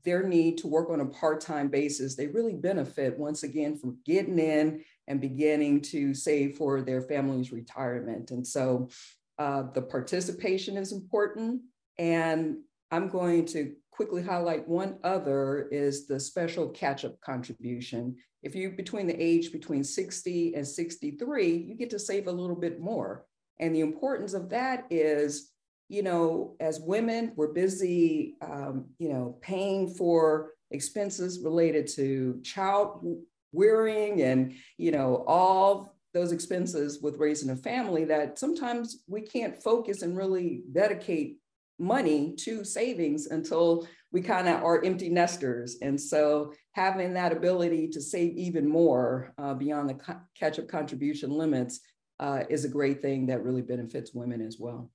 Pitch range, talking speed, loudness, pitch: 140-190 Hz, 150 wpm, -29 LUFS, 160 Hz